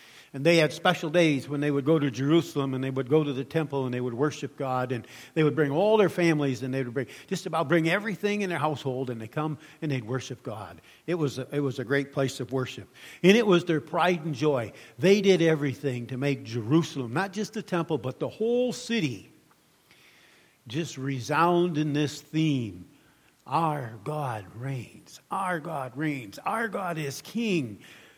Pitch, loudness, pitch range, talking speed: 145 Hz, -27 LUFS, 130-165 Hz, 200 wpm